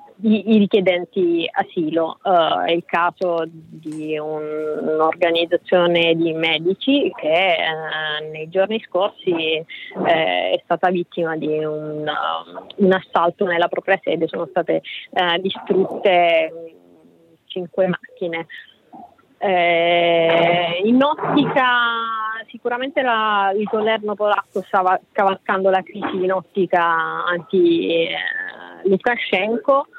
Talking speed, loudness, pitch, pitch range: 95 wpm, -19 LUFS, 180 Hz, 165-210 Hz